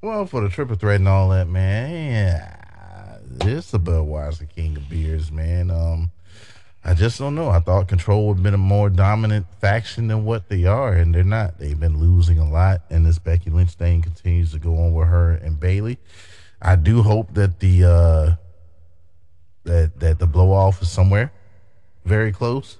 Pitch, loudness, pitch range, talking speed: 90 Hz, -19 LUFS, 85-100 Hz, 190 wpm